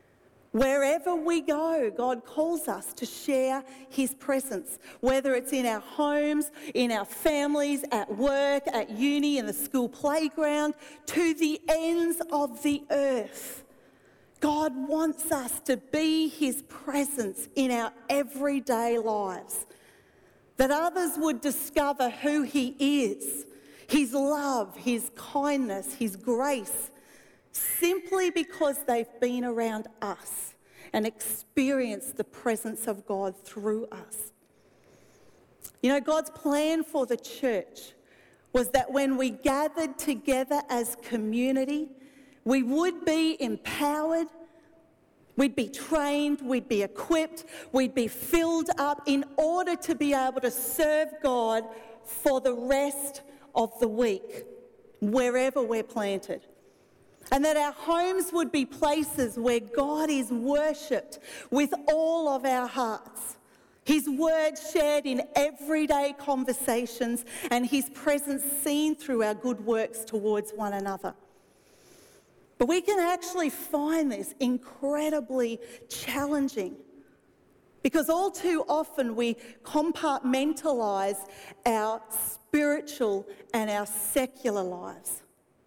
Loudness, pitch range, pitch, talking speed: -28 LUFS, 240-300 Hz, 275 Hz, 120 wpm